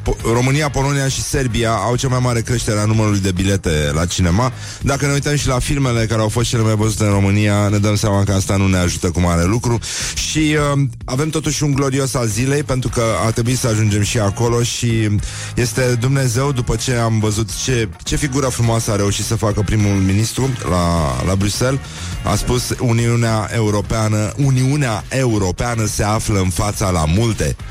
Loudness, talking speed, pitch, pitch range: -17 LUFS, 190 wpm, 115 Hz, 105-125 Hz